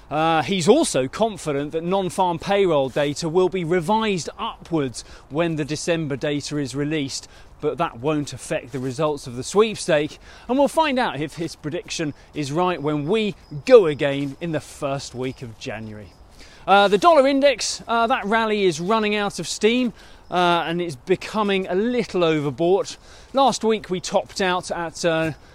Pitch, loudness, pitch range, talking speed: 170 Hz, -21 LUFS, 145-200 Hz, 170 wpm